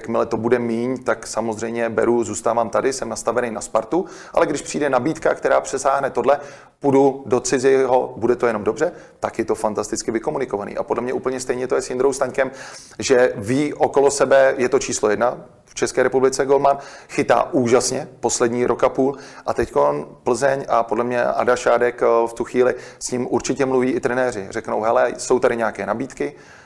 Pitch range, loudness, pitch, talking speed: 115-135 Hz, -20 LUFS, 125 Hz, 185 wpm